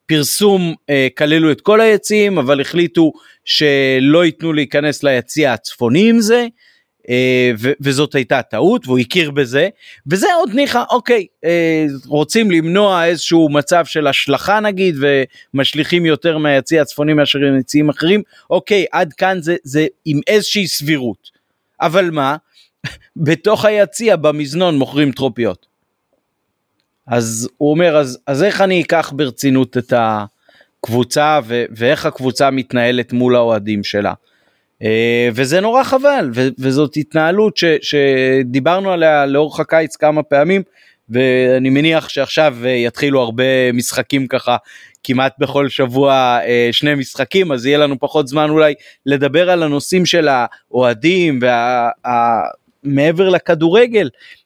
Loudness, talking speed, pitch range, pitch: -14 LUFS, 130 wpm, 130-170 Hz, 150 Hz